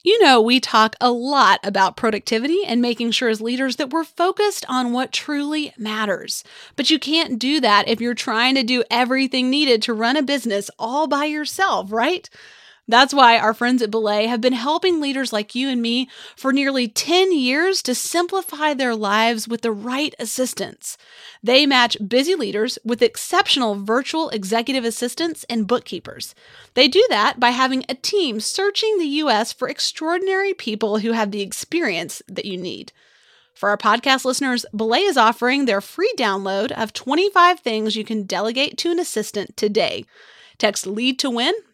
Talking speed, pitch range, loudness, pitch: 175 wpm, 225-305 Hz, -19 LUFS, 250 Hz